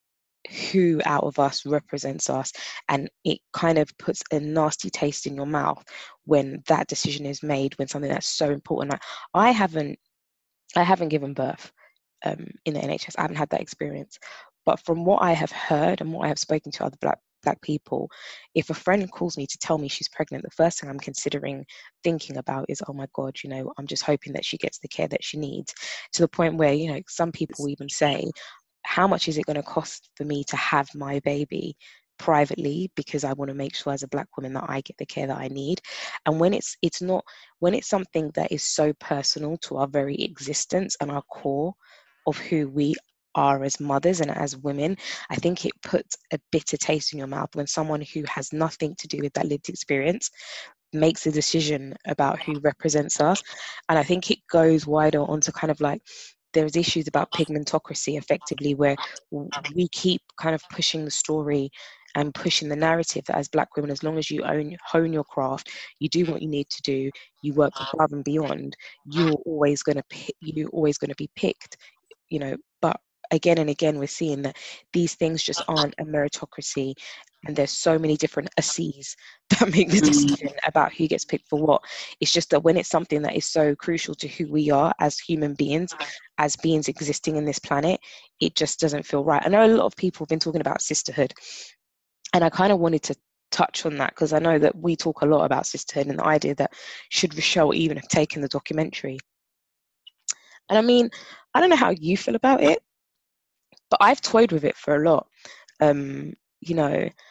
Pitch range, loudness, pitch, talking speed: 145-165 Hz, -24 LUFS, 150 Hz, 210 wpm